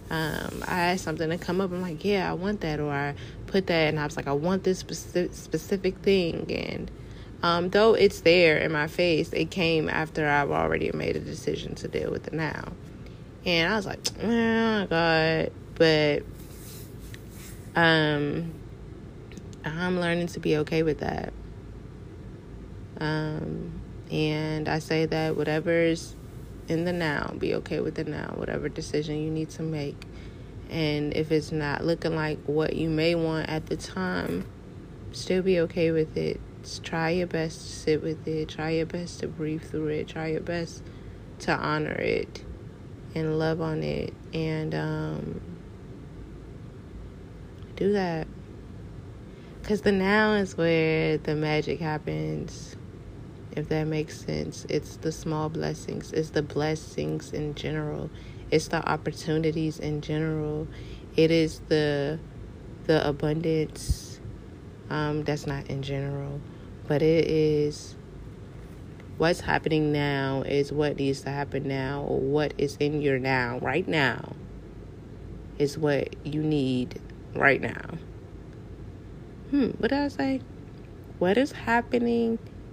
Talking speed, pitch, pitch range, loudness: 145 wpm, 155 Hz, 140-165 Hz, -27 LUFS